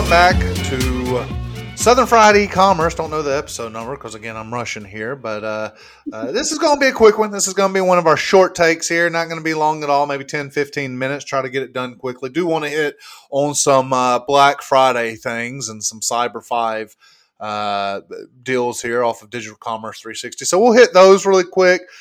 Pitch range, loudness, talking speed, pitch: 115-175 Hz, -16 LUFS, 220 wpm, 140 Hz